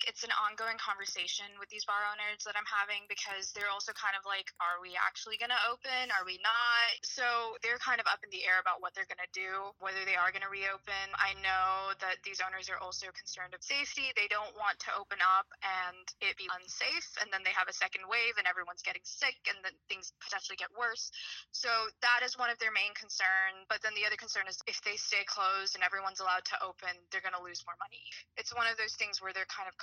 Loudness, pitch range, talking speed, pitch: -34 LUFS, 190-220 Hz, 235 wpm, 200 Hz